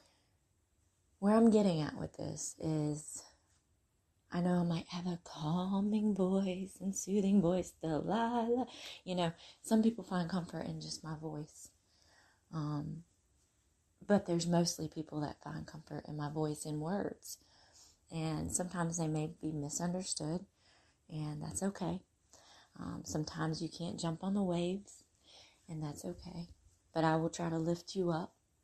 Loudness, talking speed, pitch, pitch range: -37 LUFS, 145 wpm, 165 Hz, 150-180 Hz